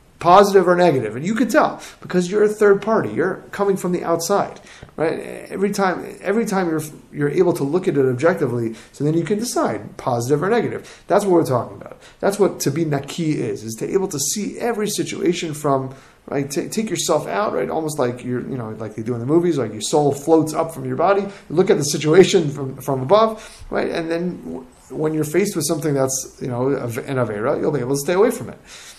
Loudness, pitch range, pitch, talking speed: -19 LUFS, 135-190 Hz, 165 Hz, 230 wpm